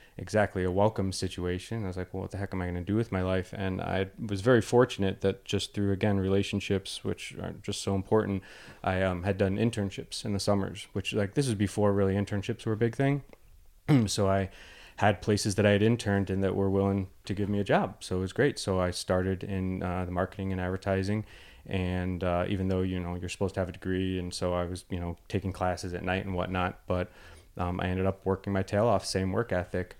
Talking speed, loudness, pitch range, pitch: 240 wpm, -30 LUFS, 90-105 Hz, 95 Hz